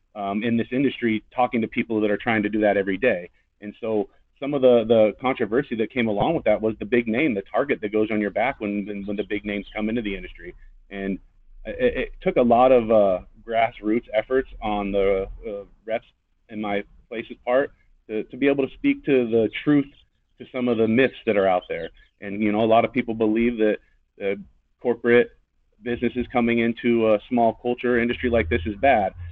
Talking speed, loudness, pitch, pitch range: 215 wpm, -23 LUFS, 110 Hz, 105-120 Hz